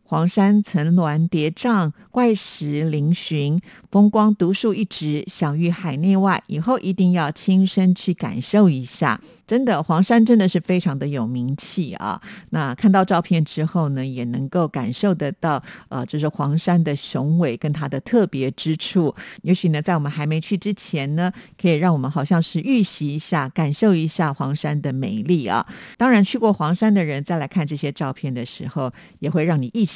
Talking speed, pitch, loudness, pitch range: 270 characters per minute, 170 Hz, -20 LUFS, 150-195 Hz